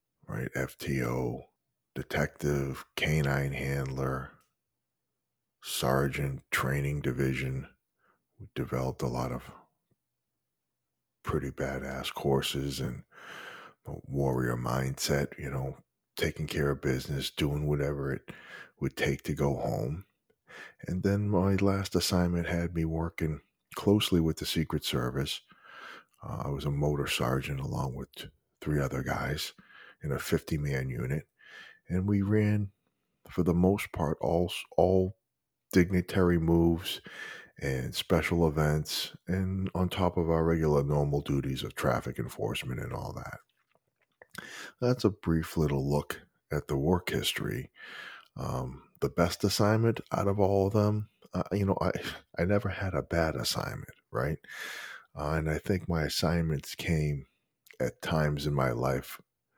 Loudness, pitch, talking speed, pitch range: -31 LUFS, 75 Hz, 135 wpm, 70-90 Hz